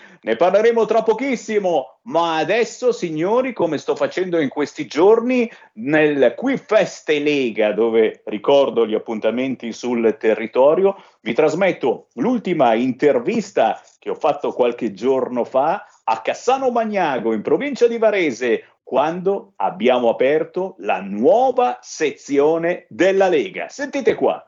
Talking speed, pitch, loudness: 125 wpm, 185 Hz, -18 LUFS